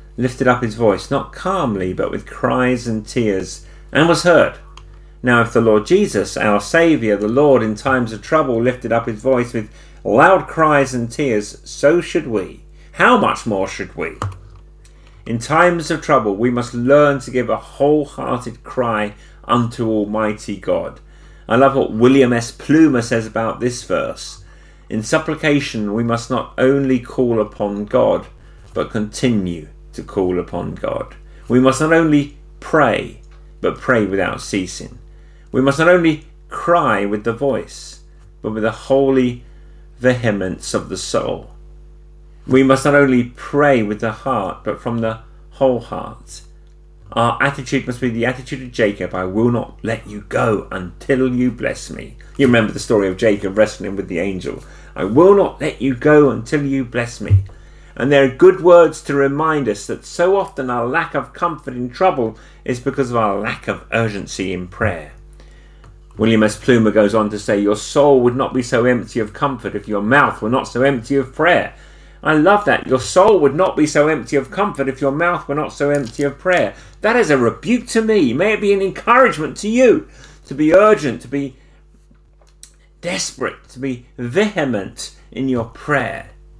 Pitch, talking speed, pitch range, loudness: 125 Hz, 180 wpm, 110-140 Hz, -16 LUFS